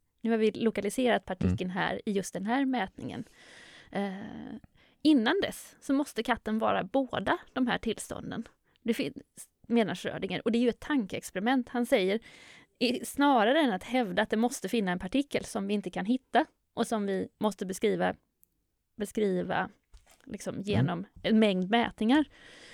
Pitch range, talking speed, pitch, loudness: 205-250 Hz, 155 wpm, 230 Hz, -30 LUFS